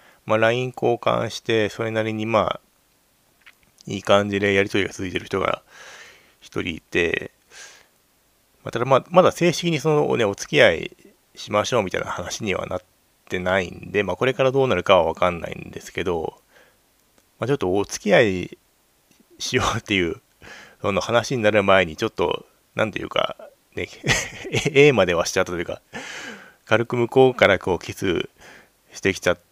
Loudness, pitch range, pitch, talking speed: -21 LUFS, 100-130 Hz, 115 Hz, 325 characters per minute